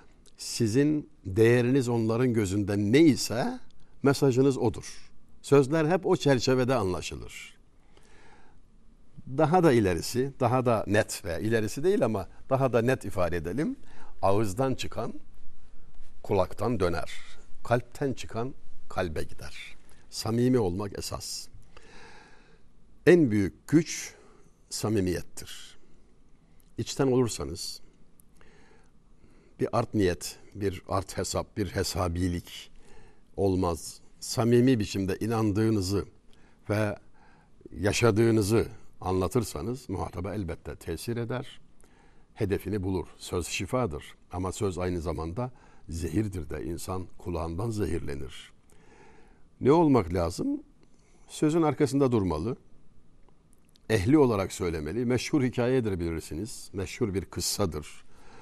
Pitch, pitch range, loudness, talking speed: 105 Hz, 90-125 Hz, -28 LUFS, 95 wpm